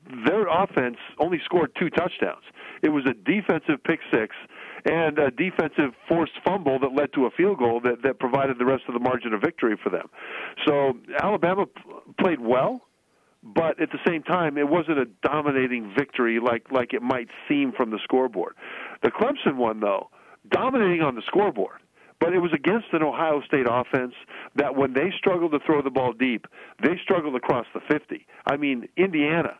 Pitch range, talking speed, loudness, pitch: 130-180 Hz, 185 wpm, -24 LUFS, 145 Hz